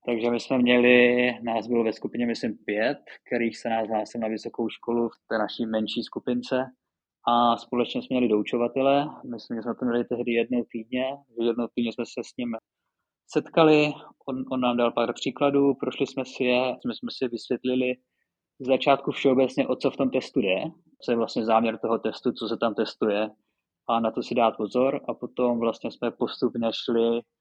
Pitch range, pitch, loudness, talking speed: 115-130 Hz, 120 Hz, -26 LUFS, 190 wpm